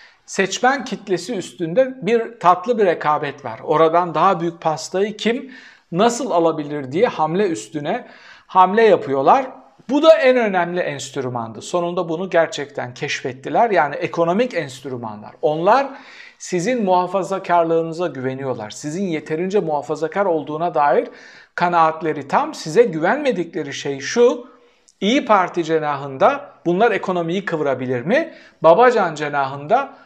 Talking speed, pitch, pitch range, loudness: 110 wpm, 170 Hz, 150-210 Hz, -19 LUFS